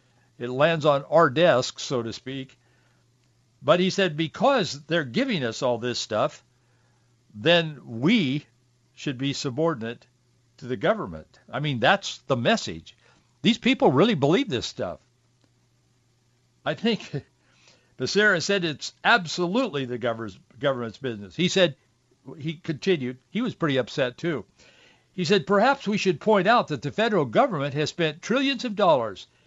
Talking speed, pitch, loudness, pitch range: 145 wpm, 140 Hz, -24 LUFS, 120-180 Hz